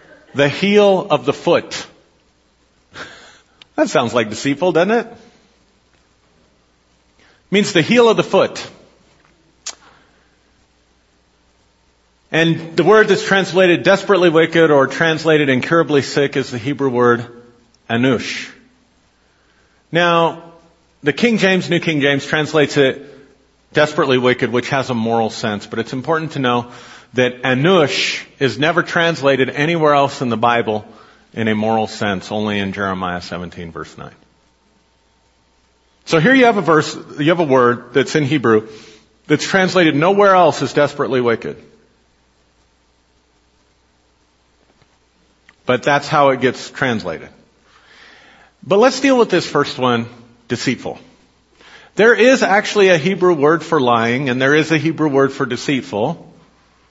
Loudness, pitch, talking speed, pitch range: -15 LUFS, 135 Hz, 130 wpm, 110-165 Hz